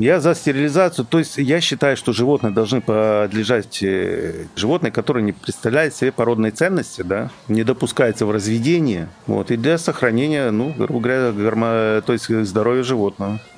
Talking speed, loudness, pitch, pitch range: 155 wpm, -19 LUFS, 120 Hz, 110-145 Hz